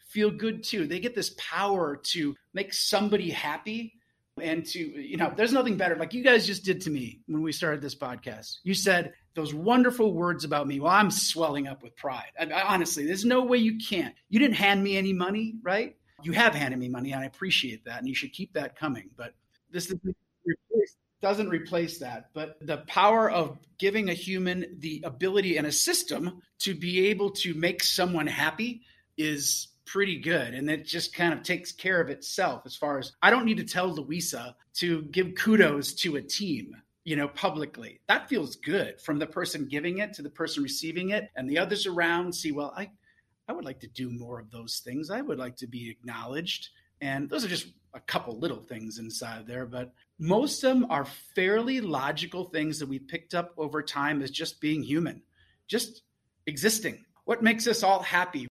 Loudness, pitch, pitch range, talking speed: -28 LUFS, 170 Hz, 145-200 Hz, 205 wpm